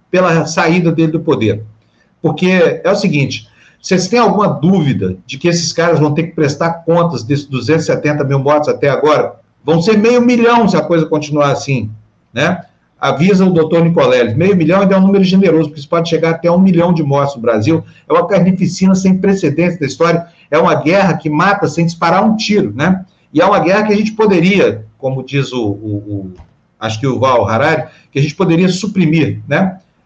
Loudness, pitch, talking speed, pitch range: -12 LUFS, 165 Hz, 200 wpm, 140-185 Hz